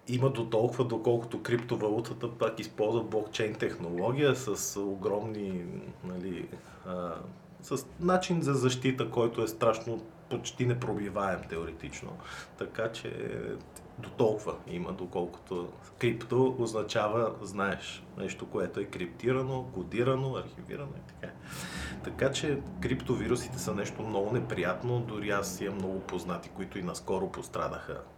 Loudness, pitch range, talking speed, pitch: -33 LUFS, 100-130 Hz, 120 wpm, 115 Hz